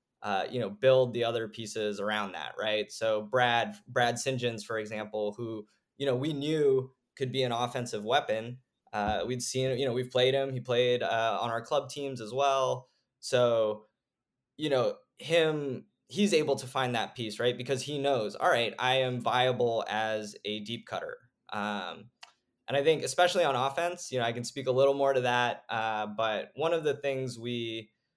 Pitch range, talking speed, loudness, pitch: 115-135 Hz, 190 wpm, -30 LUFS, 125 Hz